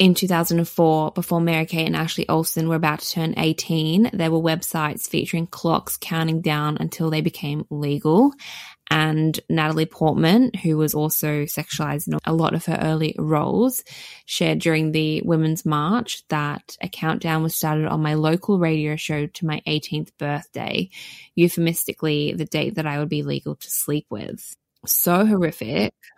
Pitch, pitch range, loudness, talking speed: 160 Hz, 155-170 Hz, -21 LUFS, 160 wpm